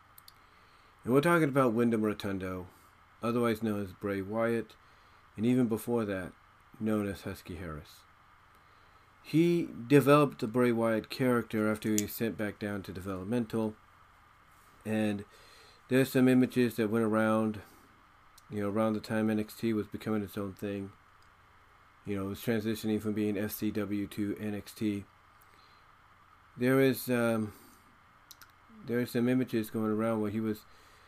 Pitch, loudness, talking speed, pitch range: 110 Hz, -31 LUFS, 145 wpm, 100-115 Hz